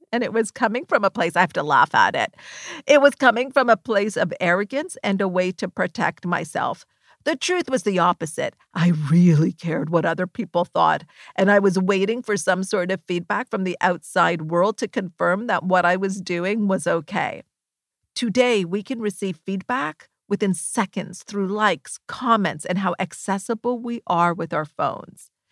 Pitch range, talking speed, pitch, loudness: 180-230 Hz, 185 wpm, 195 Hz, -21 LUFS